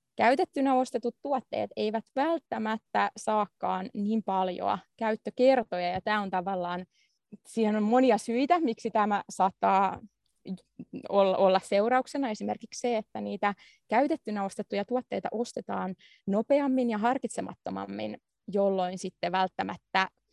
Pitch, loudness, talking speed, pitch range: 215 Hz, -29 LUFS, 105 wpm, 190-245 Hz